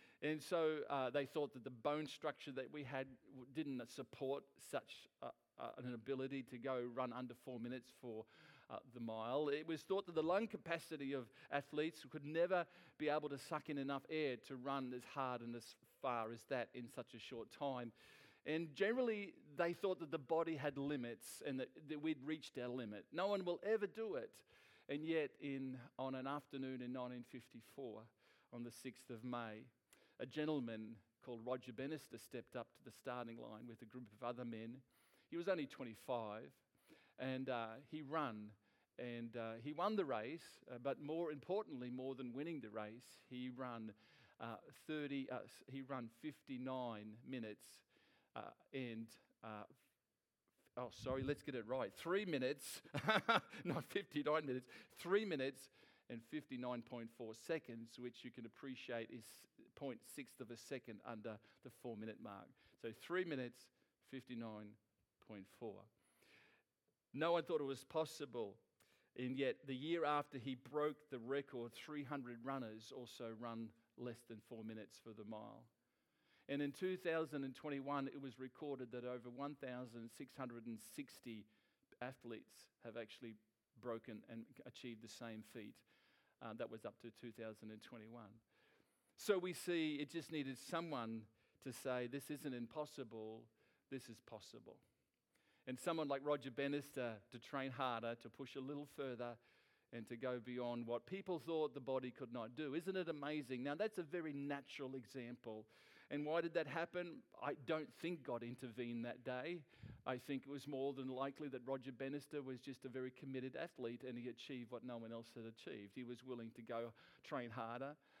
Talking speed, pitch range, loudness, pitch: 170 wpm, 120-145 Hz, -47 LUFS, 130 Hz